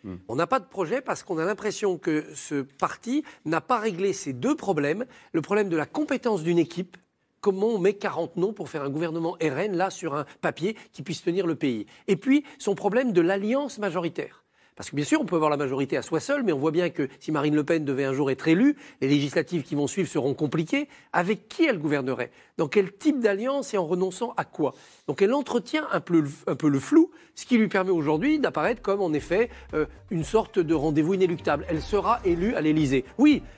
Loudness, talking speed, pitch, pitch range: -26 LUFS, 225 wpm, 180 Hz, 155-220 Hz